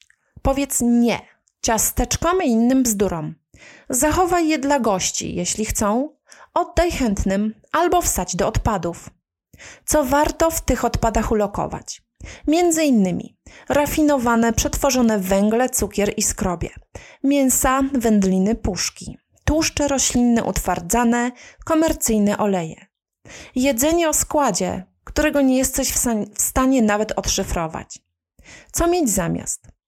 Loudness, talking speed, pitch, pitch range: -19 LUFS, 105 wpm, 240 Hz, 200-290 Hz